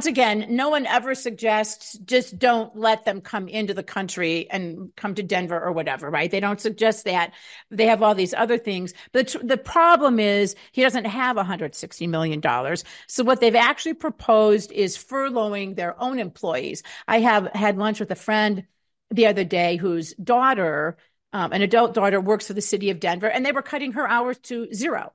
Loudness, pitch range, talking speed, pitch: -22 LUFS, 190-240 Hz, 190 wpm, 215 Hz